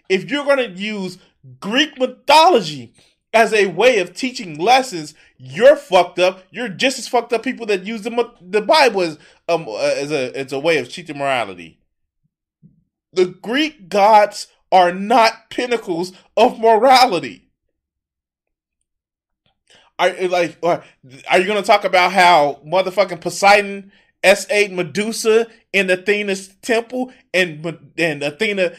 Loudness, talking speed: -16 LUFS, 135 wpm